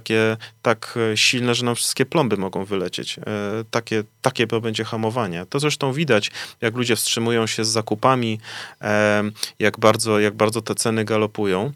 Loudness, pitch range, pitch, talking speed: -21 LUFS, 105-120 Hz, 110 Hz, 150 wpm